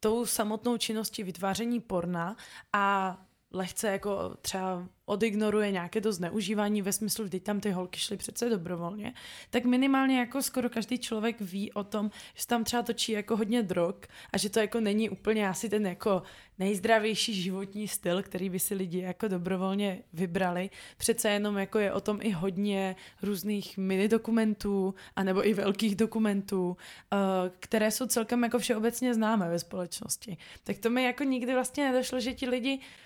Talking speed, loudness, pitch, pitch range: 165 wpm, -30 LUFS, 210 Hz, 190-230 Hz